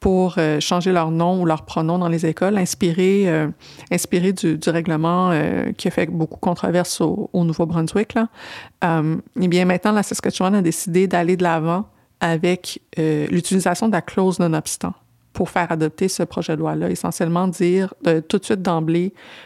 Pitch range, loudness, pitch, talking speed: 165-185 Hz, -20 LUFS, 175 Hz, 180 wpm